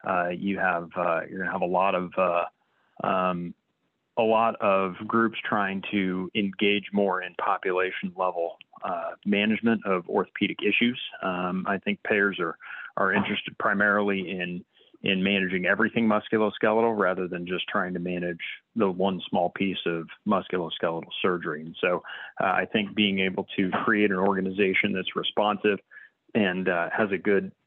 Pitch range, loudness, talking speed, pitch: 90-105 Hz, -26 LUFS, 160 wpm, 95 Hz